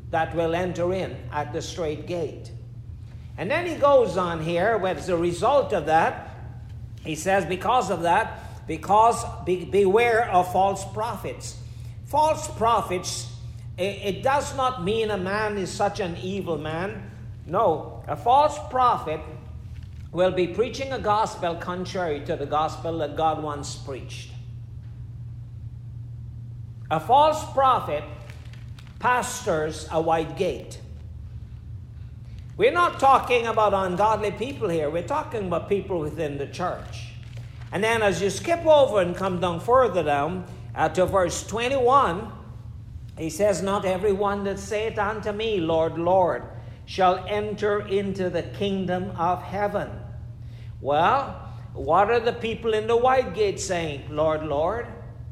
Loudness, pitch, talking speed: -24 LUFS, 170 Hz, 135 wpm